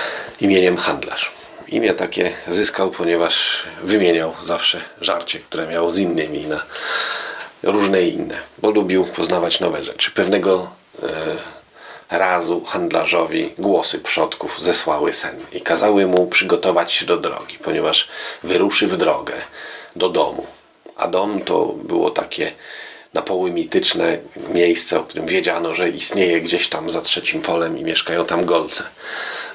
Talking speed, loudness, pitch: 130 wpm, -18 LUFS, 95 Hz